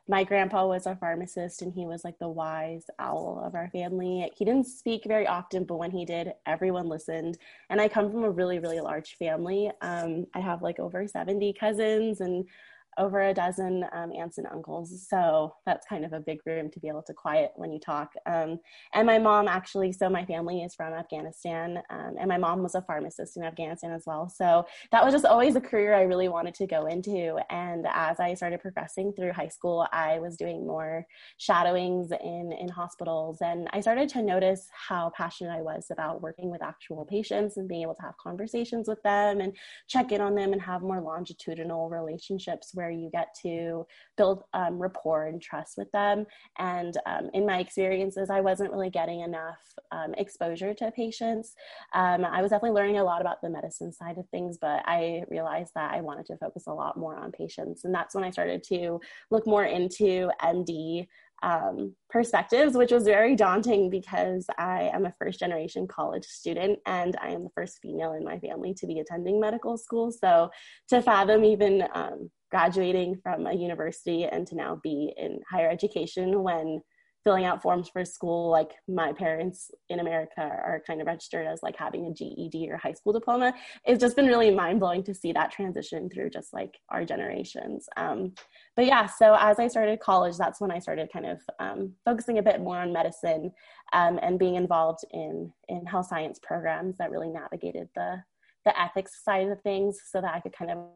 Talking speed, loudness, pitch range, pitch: 200 wpm, -28 LUFS, 170-205 Hz, 180 Hz